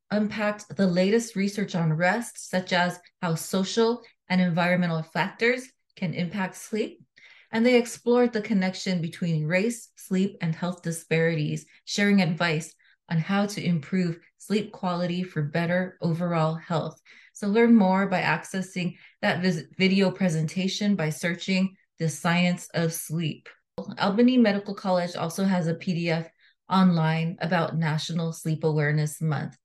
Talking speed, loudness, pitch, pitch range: 135 wpm, -26 LUFS, 180 Hz, 165-195 Hz